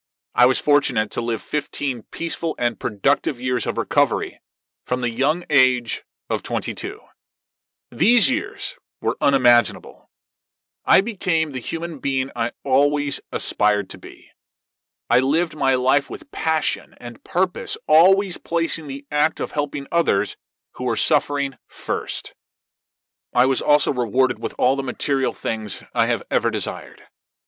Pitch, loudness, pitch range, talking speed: 140 Hz, -21 LUFS, 120-165 Hz, 140 wpm